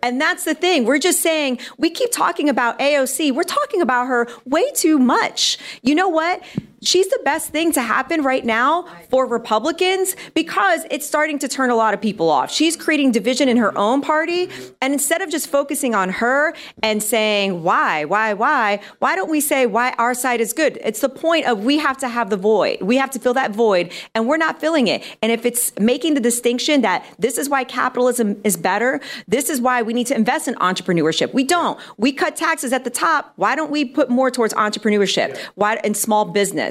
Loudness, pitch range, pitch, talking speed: -18 LUFS, 230-310 Hz, 260 Hz, 215 wpm